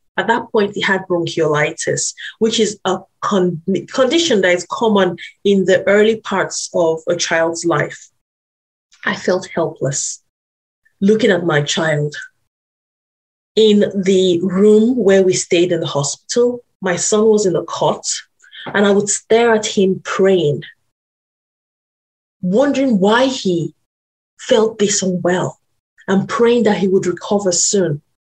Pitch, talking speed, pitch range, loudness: 190 Hz, 135 wpm, 170-215 Hz, -15 LUFS